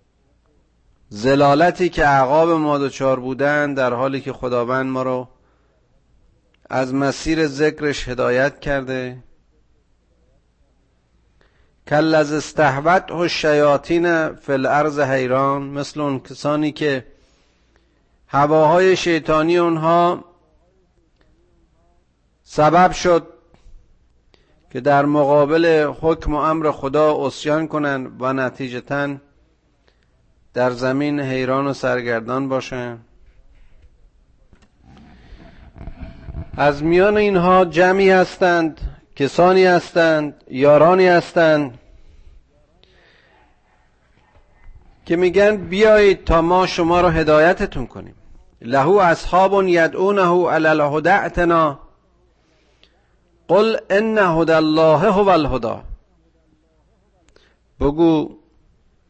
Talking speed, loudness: 80 wpm, -17 LUFS